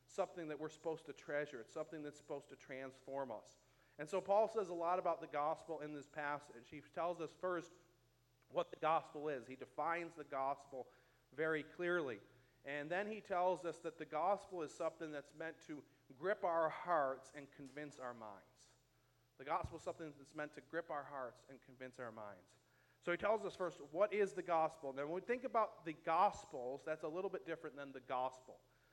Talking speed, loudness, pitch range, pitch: 200 wpm, -43 LUFS, 140-175 Hz, 155 Hz